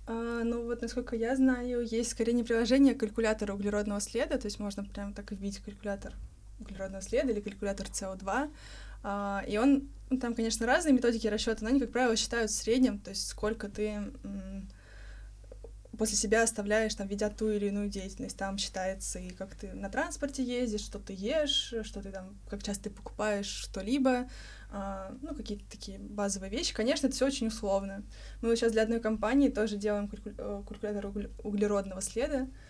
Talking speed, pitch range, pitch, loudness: 175 wpm, 200-235 Hz, 215 Hz, -32 LUFS